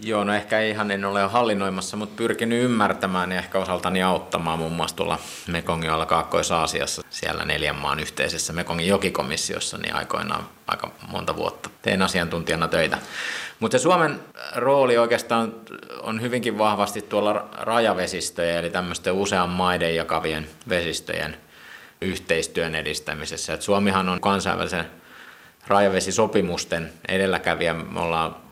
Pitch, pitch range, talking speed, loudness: 95 Hz, 85-105 Hz, 125 wpm, -23 LUFS